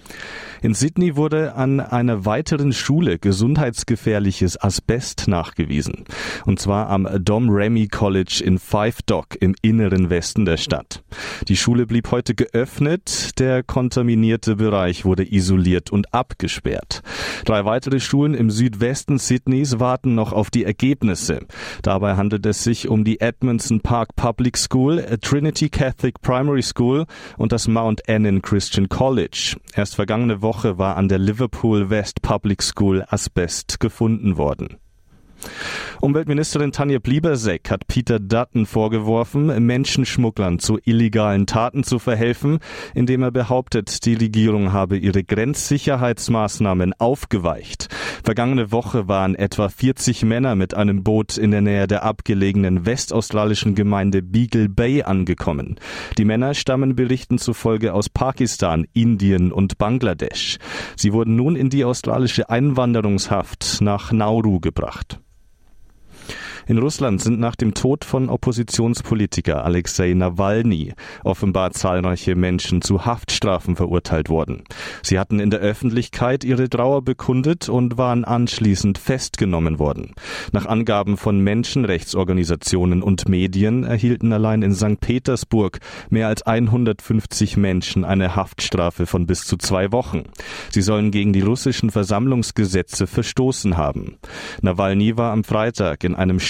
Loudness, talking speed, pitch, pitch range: -19 LUFS, 130 wpm, 110 Hz, 95-120 Hz